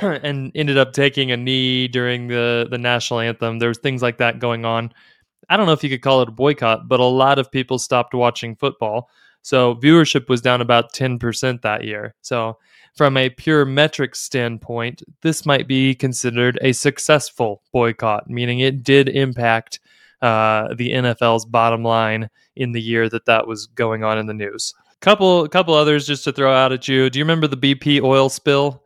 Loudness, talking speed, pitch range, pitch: -17 LUFS, 195 wpm, 115-140 Hz, 125 Hz